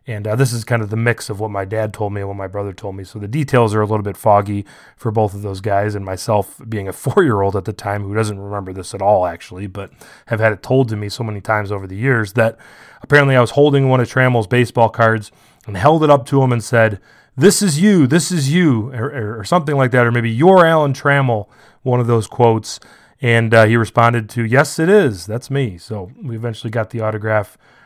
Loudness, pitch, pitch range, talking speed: -16 LUFS, 115 Hz, 105-130 Hz, 250 wpm